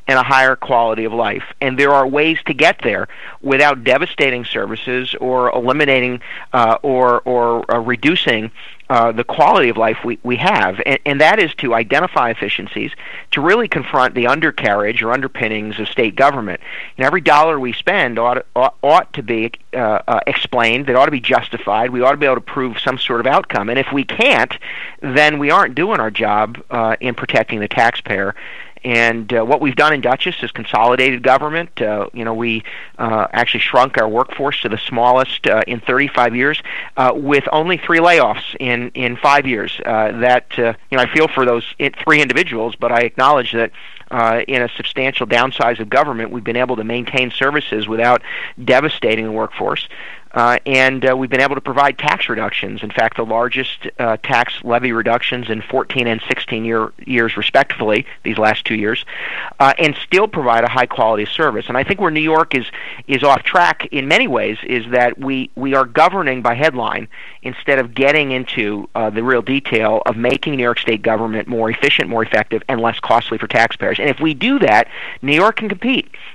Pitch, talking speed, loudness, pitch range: 125 Hz, 195 wpm, -15 LUFS, 115-135 Hz